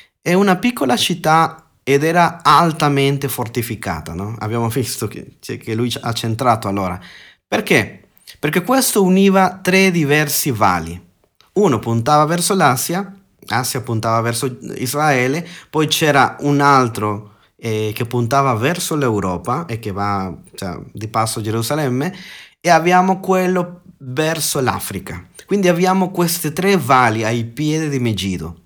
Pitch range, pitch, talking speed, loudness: 115-170 Hz, 135 Hz, 135 wpm, -16 LUFS